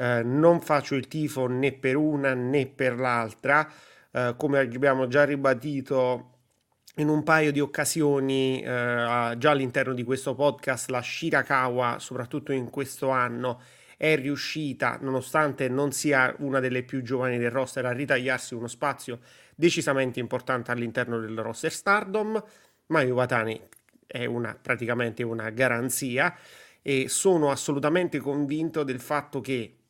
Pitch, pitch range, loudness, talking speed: 135 Hz, 125-145 Hz, -26 LUFS, 135 wpm